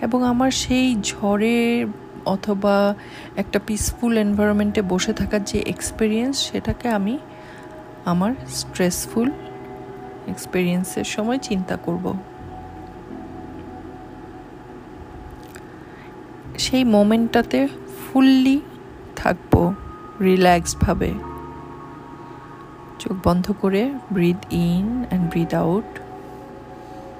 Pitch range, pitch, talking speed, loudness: 195-245 Hz, 210 Hz, 75 wpm, -21 LUFS